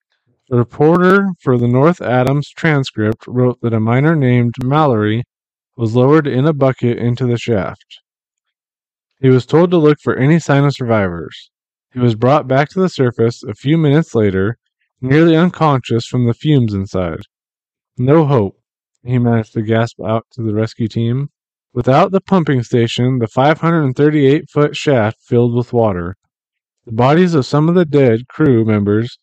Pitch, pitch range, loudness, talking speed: 125 Hz, 115-150 Hz, -14 LUFS, 160 wpm